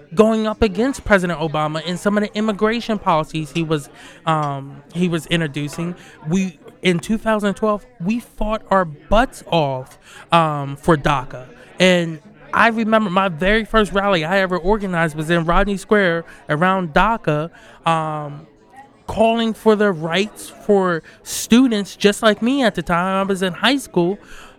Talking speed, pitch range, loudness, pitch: 150 wpm, 165-215 Hz, -18 LUFS, 185 Hz